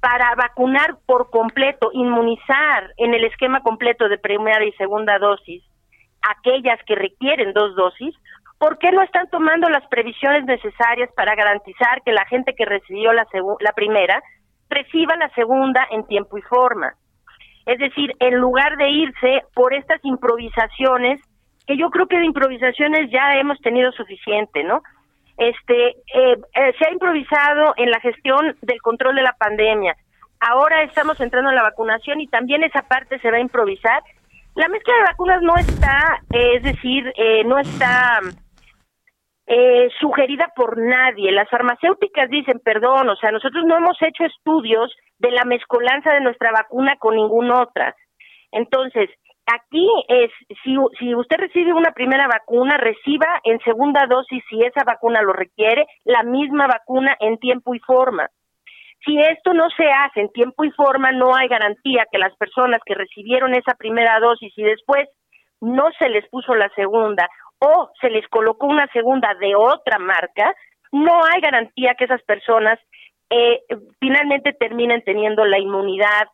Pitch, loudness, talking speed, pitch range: 250 Hz, -17 LUFS, 160 wpm, 225-290 Hz